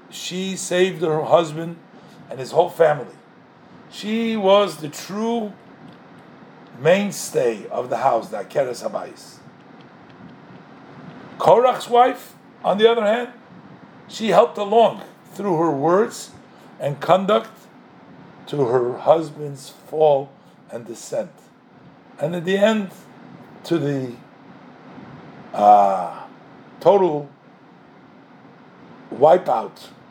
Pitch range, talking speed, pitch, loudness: 155-220 Hz, 95 wpm, 185 Hz, -19 LUFS